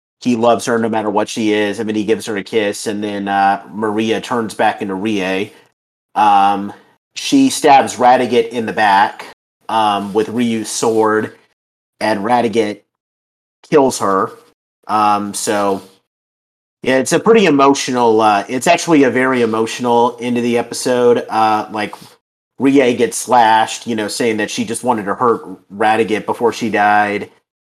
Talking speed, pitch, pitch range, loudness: 160 wpm, 110 Hz, 105-120 Hz, -15 LUFS